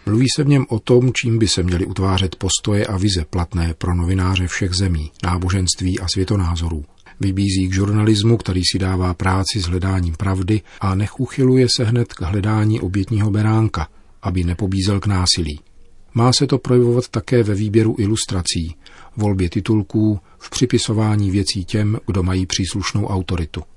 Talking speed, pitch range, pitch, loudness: 160 wpm, 90-110 Hz, 100 Hz, -18 LUFS